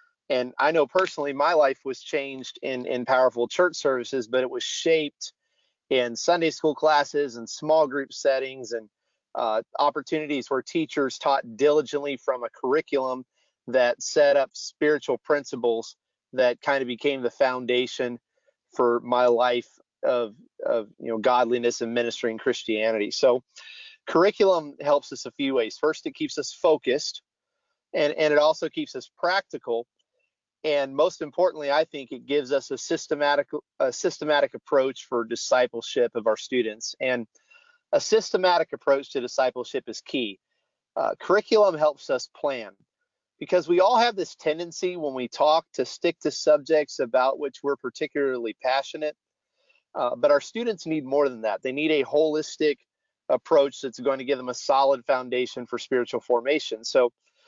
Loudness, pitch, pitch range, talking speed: -25 LUFS, 145 Hz, 125-165 Hz, 155 wpm